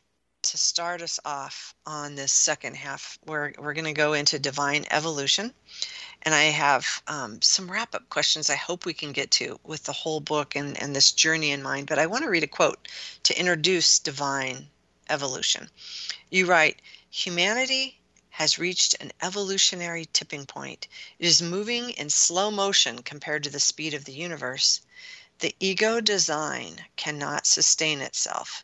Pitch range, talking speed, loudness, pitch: 145-185 Hz, 165 wpm, -24 LUFS, 155 Hz